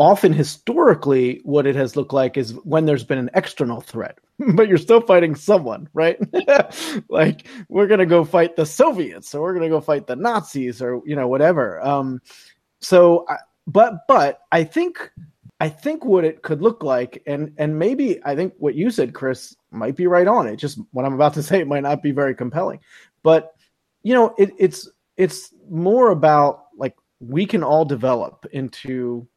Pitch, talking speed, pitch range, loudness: 155 Hz, 190 wpm, 140-185 Hz, -18 LUFS